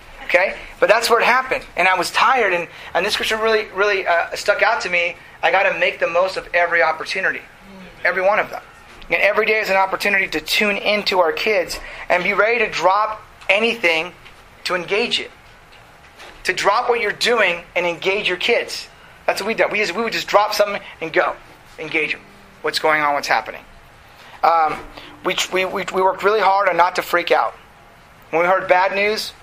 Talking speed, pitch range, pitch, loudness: 200 wpm, 175-210 Hz, 190 Hz, -18 LUFS